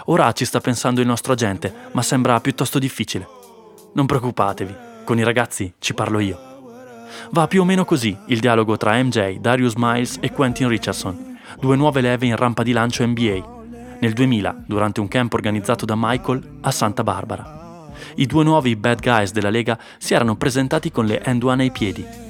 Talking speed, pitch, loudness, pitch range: 185 wpm, 120 Hz, -19 LUFS, 110-135 Hz